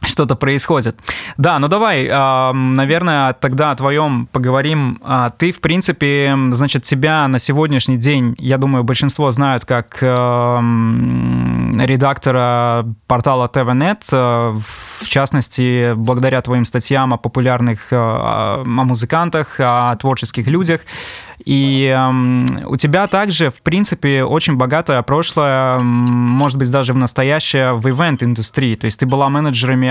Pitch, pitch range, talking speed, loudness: 130 Hz, 125-145 Hz, 120 wpm, -14 LUFS